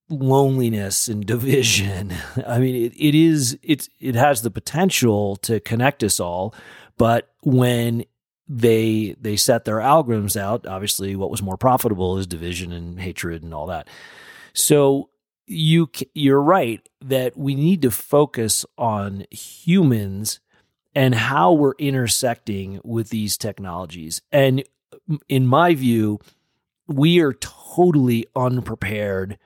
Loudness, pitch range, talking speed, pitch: -19 LUFS, 100-140 Hz, 130 wpm, 120 Hz